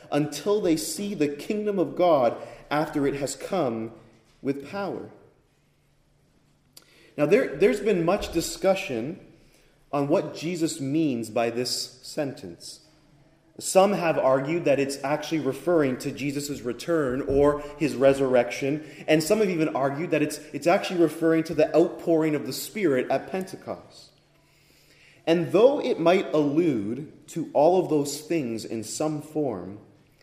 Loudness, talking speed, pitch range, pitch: -25 LUFS, 140 wpm, 140-165 Hz, 150 Hz